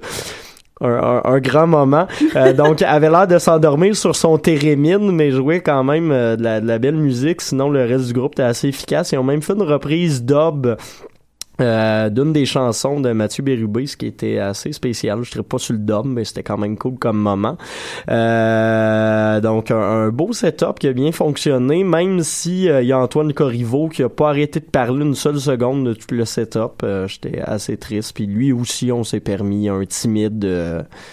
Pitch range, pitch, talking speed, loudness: 110-150 Hz, 130 Hz, 210 wpm, -17 LUFS